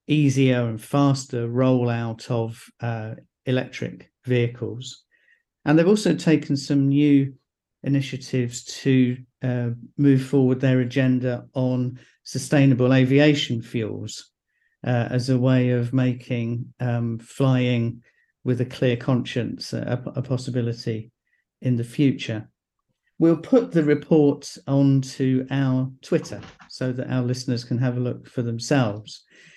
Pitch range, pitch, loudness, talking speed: 120-135 Hz, 130 Hz, -23 LUFS, 120 wpm